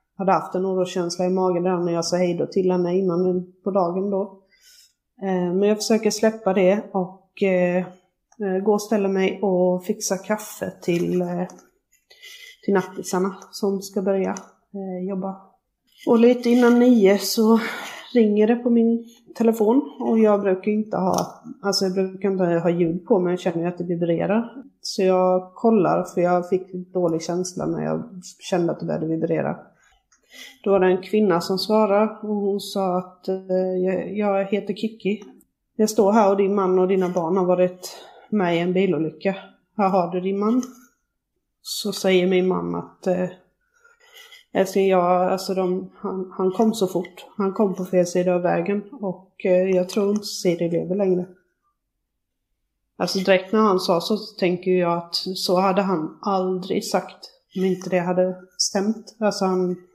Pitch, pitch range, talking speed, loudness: 190 Hz, 180-210 Hz, 165 wpm, -22 LUFS